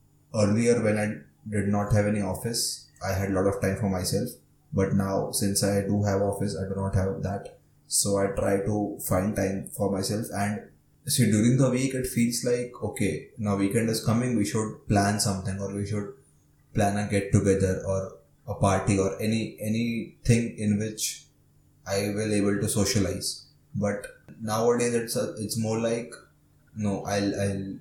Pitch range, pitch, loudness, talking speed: 100-110 Hz, 105 Hz, -27 LUFS, 180 wpm